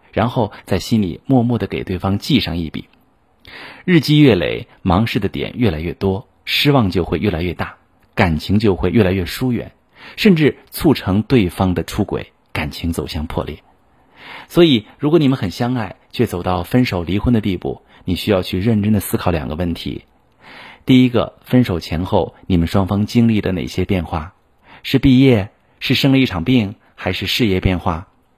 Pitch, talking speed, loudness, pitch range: 95 Hz, 260 characters per minute, -17 LUFS, 90-120 Hz